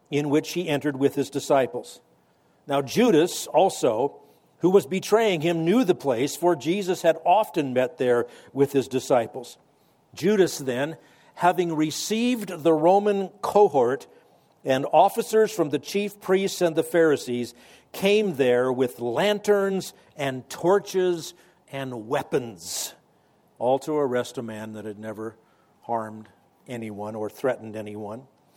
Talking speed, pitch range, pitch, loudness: 130 wpm, 125-185 Hz, 150 Hz, -24 LUFS